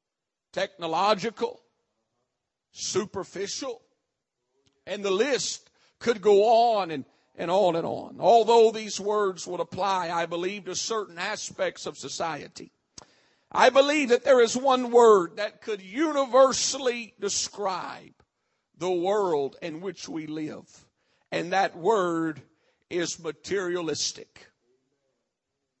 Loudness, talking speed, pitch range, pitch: -25 LUFS, 110 wpm, 170-235 Hz, 200 Hz